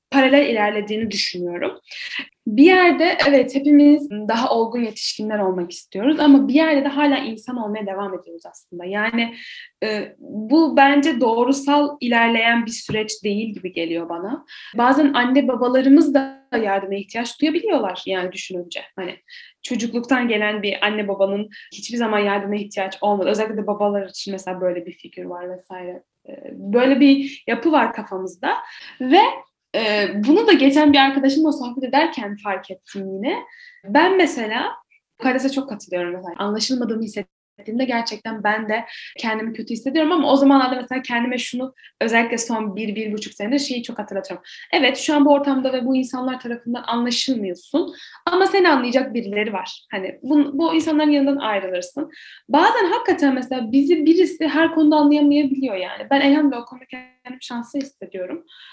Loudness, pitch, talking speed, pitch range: -19 LUFS, 250 Hz, 150 wpm, 210-290 Hz